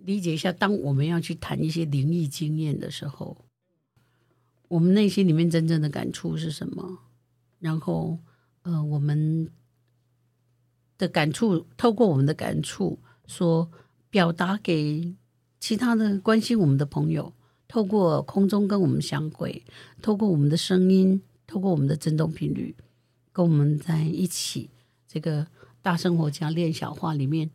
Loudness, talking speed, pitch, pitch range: -25 LUFS, 225 characters per minute, 160 Hz, 140-180 Hz